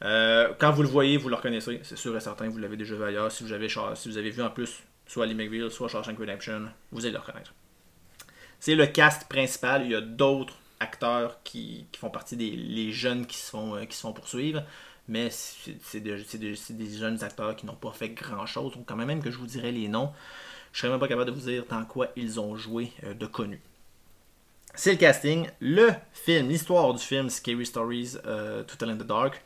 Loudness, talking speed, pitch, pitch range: -28 LUFS, 235 wpm, 120 Hz, 110-135 Hz